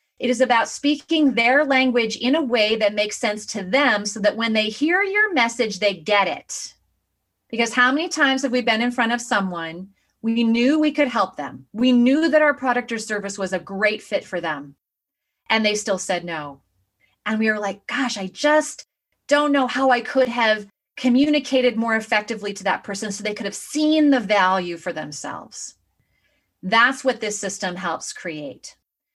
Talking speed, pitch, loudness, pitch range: 190 wpm, 230 Hz, -20 LUFS, 200-270 Hz